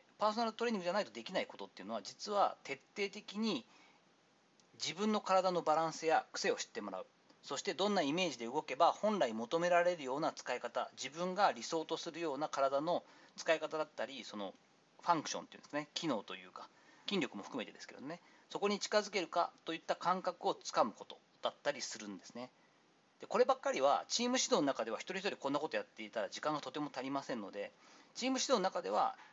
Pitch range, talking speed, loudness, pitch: 155-210 Hz, 445 characters per minute, -37 LUFS, 180 Hz